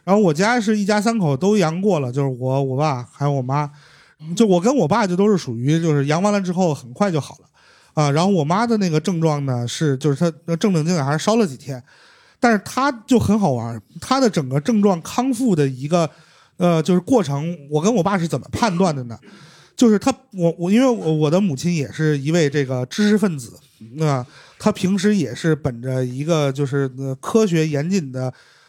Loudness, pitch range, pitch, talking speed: -19 LUFS, 145-205 Hz, 165 Hz, 300 characters per minute